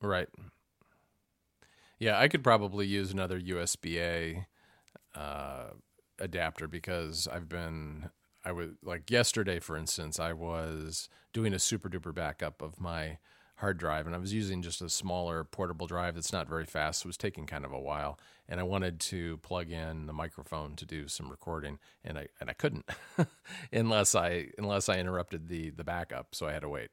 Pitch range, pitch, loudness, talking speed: 80-95 Hz, 85 Hz, -34 LUFS, 185 wpm